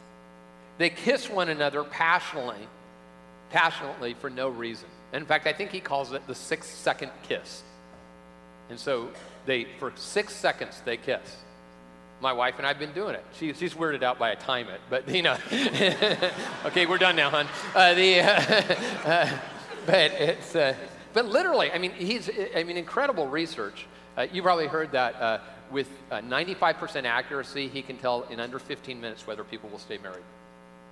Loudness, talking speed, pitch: -26 LUFS, 175 wpm, 135 Hz